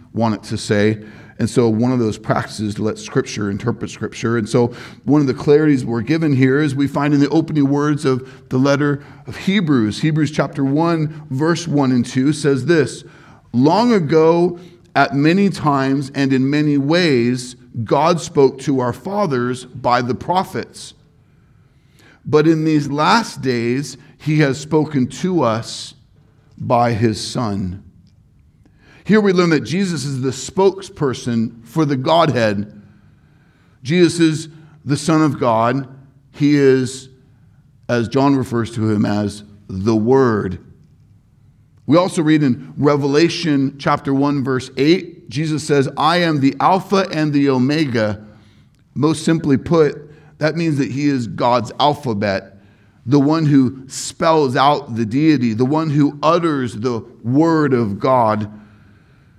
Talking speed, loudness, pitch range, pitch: 150 wpm, -17 LUFS, 120-155 Hz, 135 Hz